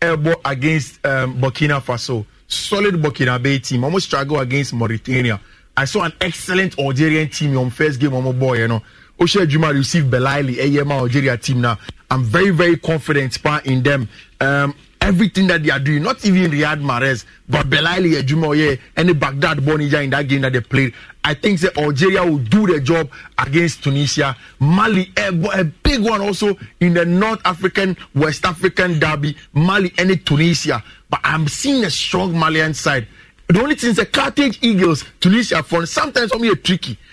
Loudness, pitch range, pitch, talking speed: -16 LUFS, 135-185 Hz, 155 Hz, 180 wpm